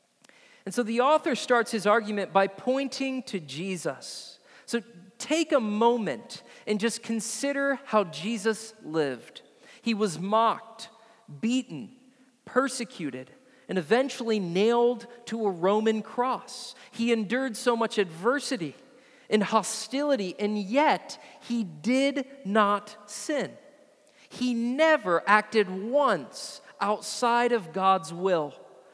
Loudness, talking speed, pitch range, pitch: -27 LUFS, 110 wpm, 205-255 Hz, 230 Hz